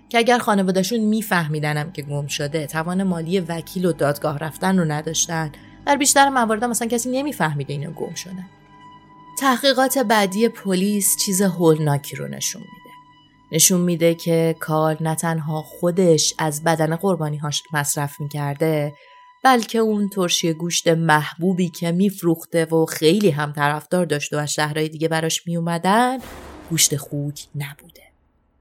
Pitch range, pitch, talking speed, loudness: 150-195 Hz, 165 Hz, 145 wpm, -20 LUFS